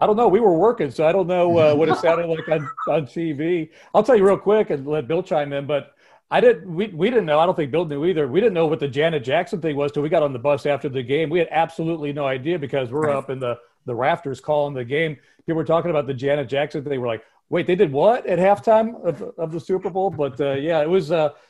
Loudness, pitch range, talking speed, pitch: -20 LUFS, 145-175 Hz, 285 wpm, 160 Hz